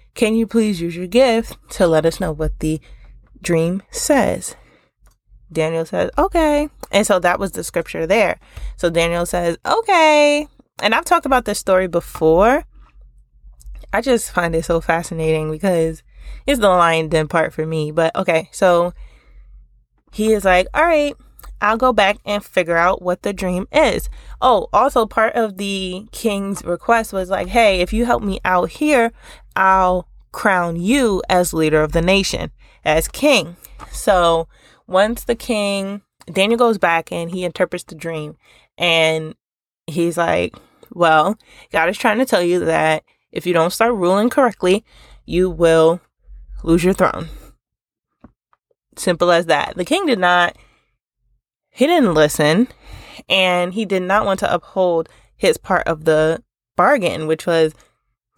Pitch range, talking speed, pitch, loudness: 165-220 Hz, 155 wpm, 180 Hz, -17 LUFS